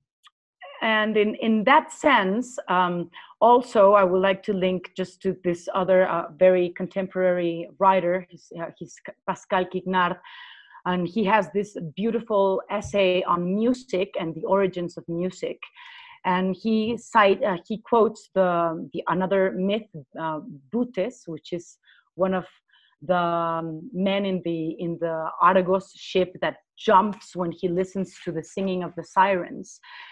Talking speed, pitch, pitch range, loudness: 145 wpm, 185 Hz, 175-205 Hz, -24 LUFS